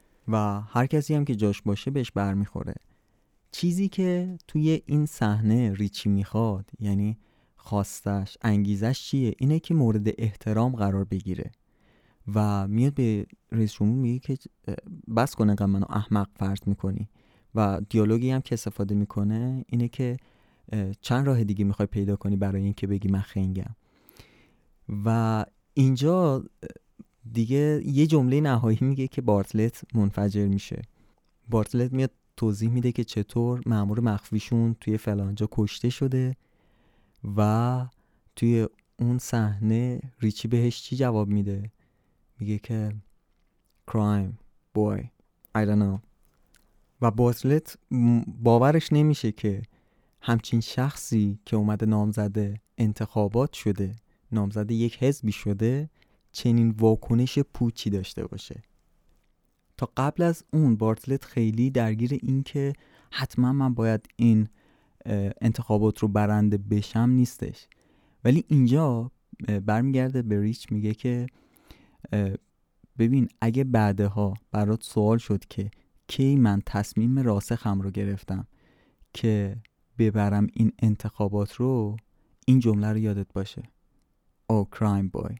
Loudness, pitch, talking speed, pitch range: -26 LUFS, 110 Hz, 120 wpm, 105-125 Hz